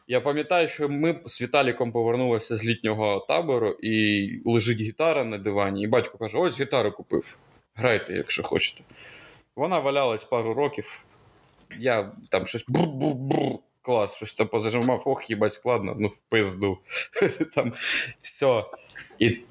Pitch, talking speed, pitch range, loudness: 115 Hz, 135 wpm, 105-140 Hz, -25 LUFS